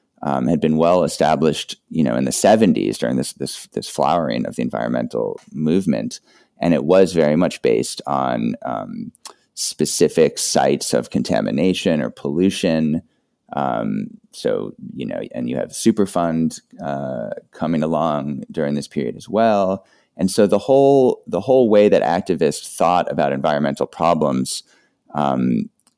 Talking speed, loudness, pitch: 145 wpm, -19 LUFS, 100 Hz